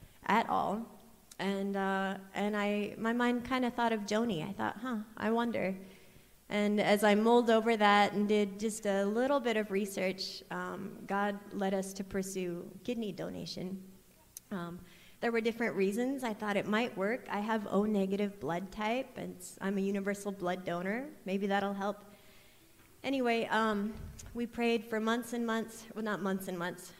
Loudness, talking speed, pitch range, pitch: -33 LUFS, 175 wpm, 195-225 Hz, 205 Hz